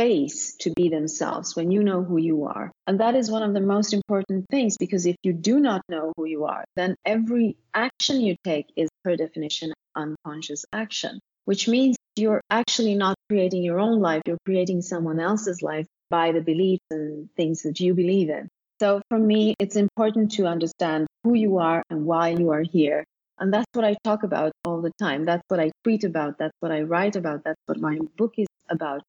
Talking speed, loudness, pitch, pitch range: 205 wpm, -24 LUFS, 185 Hz, 160-210 Hz